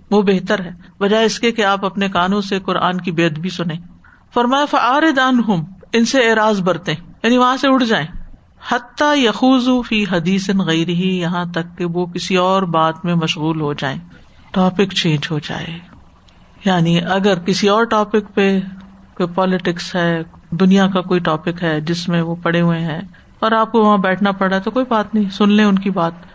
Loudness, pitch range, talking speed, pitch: -16 LUFS, 170-210 Hz, 185 wpm, 190 Hz